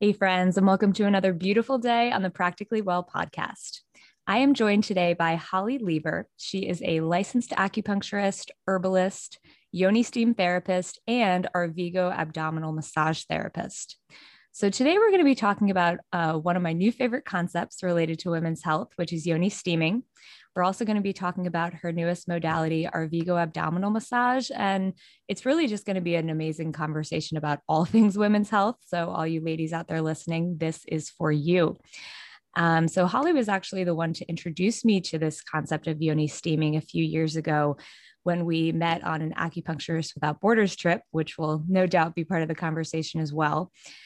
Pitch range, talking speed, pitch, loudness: 160-200 Hz, 190 wpm, 175 Hz, -26 LUFS